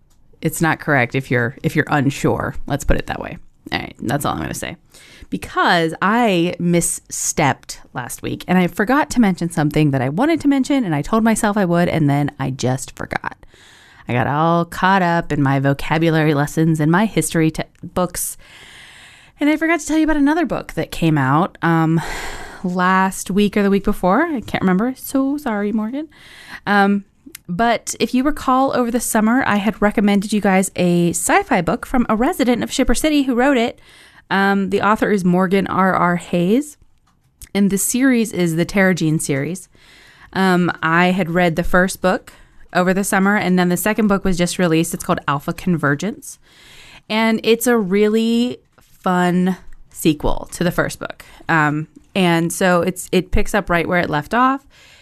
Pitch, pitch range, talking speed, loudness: 185 Hz, 165-225 Hz, 185 wpm, -17 LUFS